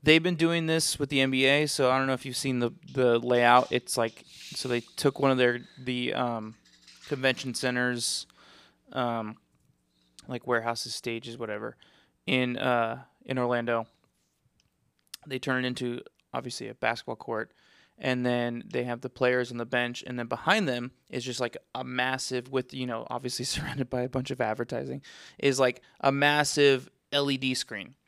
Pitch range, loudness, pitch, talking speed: 120-135 Hz, -28 LUFS, 125 Hz, 170 wpm